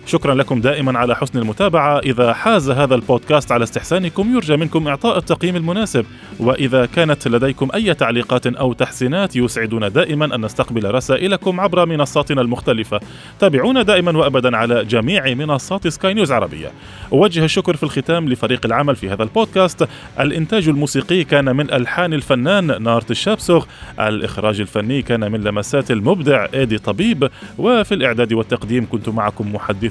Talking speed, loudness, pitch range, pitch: 145 wpm, -16 LUFS, 120-170 Hz, 135 Hz